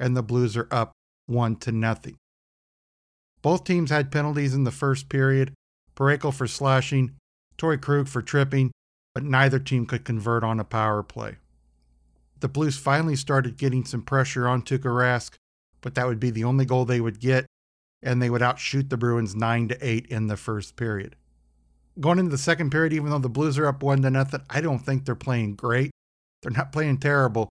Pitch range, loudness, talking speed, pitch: 115-140 Hz, -24 LUFS, 185 wpm, 125 Hz